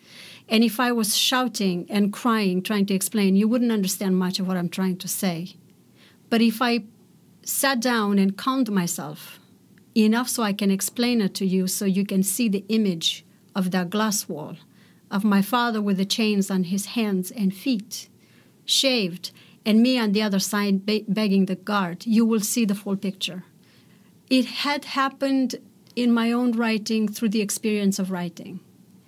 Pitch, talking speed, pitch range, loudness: 205 Hz, 175 wpm, 190-230 Hz, -23 LUFS